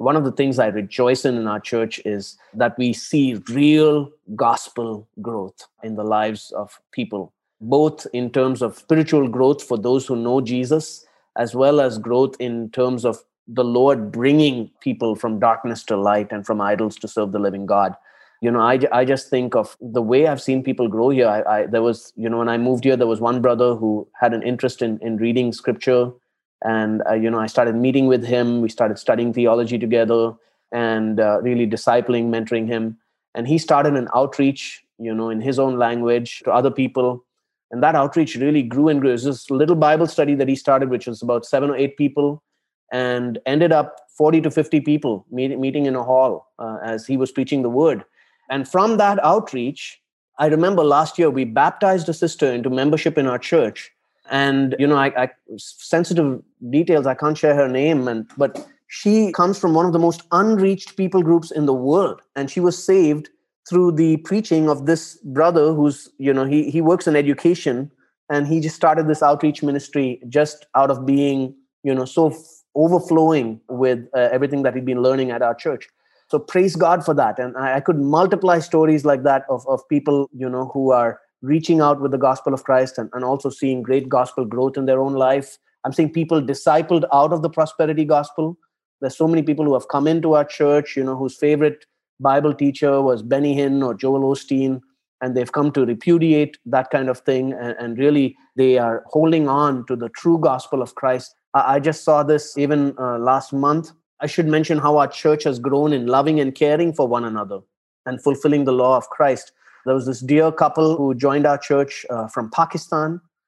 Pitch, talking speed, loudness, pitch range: 135 Hz, 205 wpm, -19 LUFS, 125-150 Hz